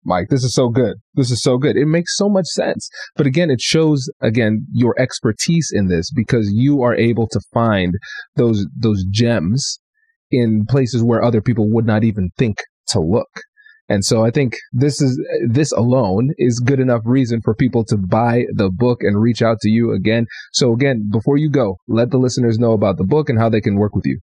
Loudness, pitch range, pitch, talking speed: -16 LUFS, 110-140 Hz, 120 Hz, 215 wpm